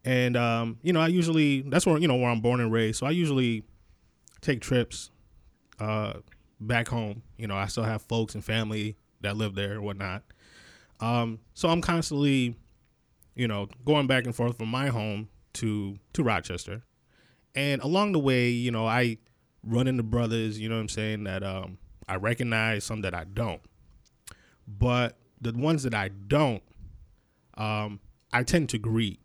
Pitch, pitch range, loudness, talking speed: 115 Hz, 105-125 Hz, -28 LUFS, 175 wpm